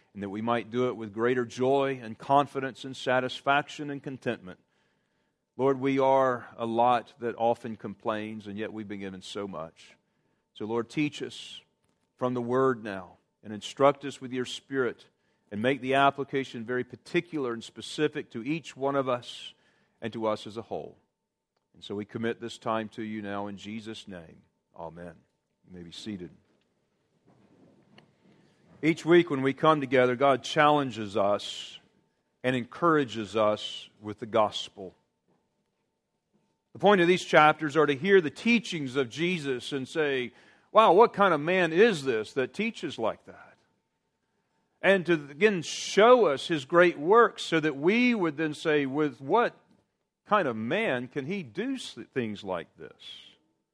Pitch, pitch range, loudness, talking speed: 130 Hz, 110-155 Hz, -27 LUFS, 160 wpm